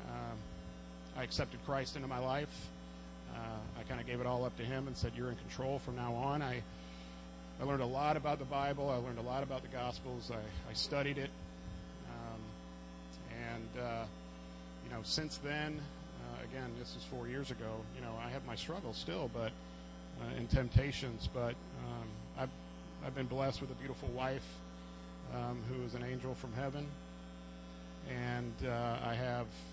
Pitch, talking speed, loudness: 115 Hz, 180 wpm, -42 LUFS